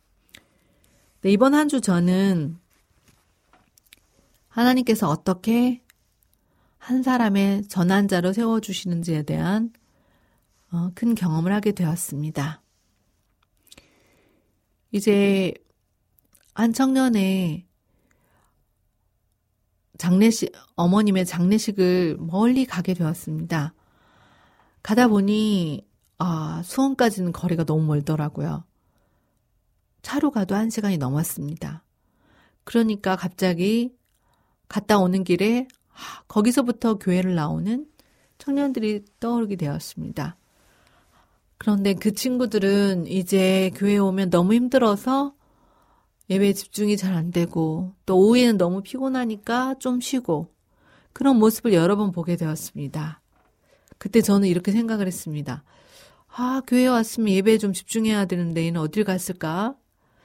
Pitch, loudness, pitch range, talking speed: 195 Hz, -22 LUFS, 165-225 Hz, 235 characters per minute